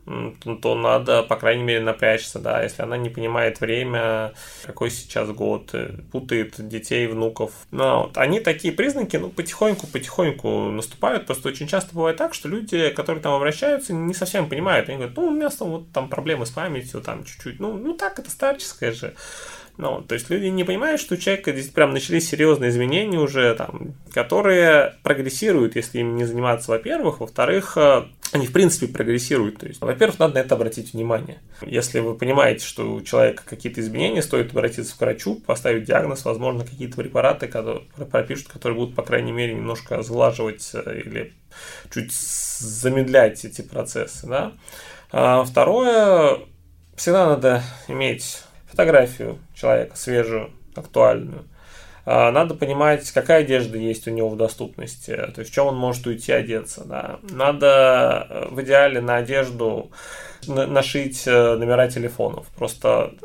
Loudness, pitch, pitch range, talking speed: -21 LUFS, 130 Hz, 115-160 Hz, 150 wpm